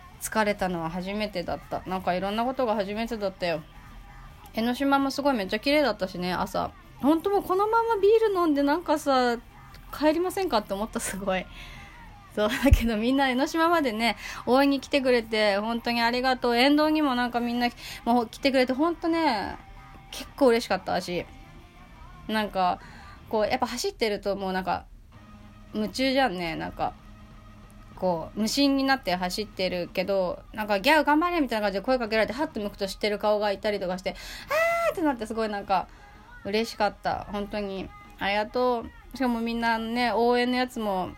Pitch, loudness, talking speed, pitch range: 225 Hz, -26 LUFS, 380 characters per minute, 195-270 Hz